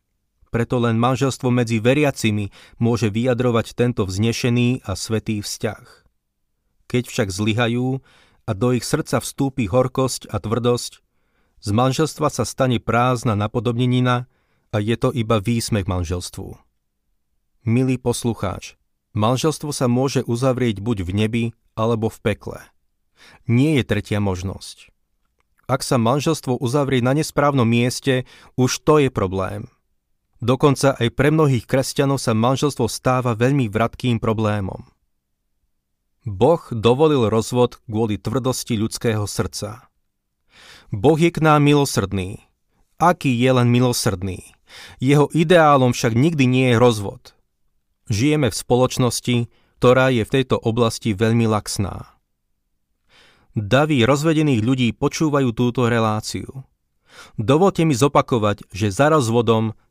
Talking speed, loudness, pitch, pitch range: 120 wpm, -19 LUFS, 120 Hz, 105-130 Hz